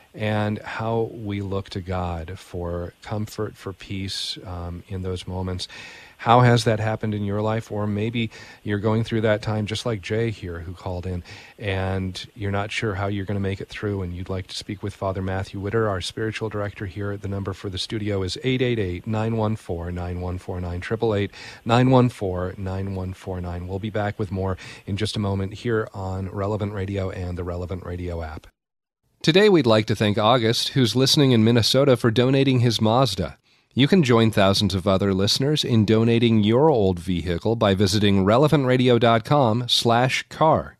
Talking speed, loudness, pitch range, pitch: 170 wpm, -22 LUFS, 95-115 Hz, 105 Hz